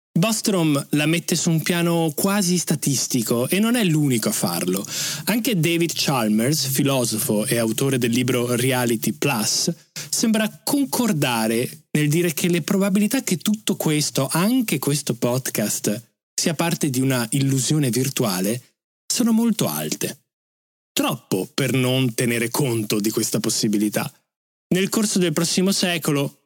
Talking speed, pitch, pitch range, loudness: 135 wpm, 150 Hz, 125-180 Hz, -21 LUFS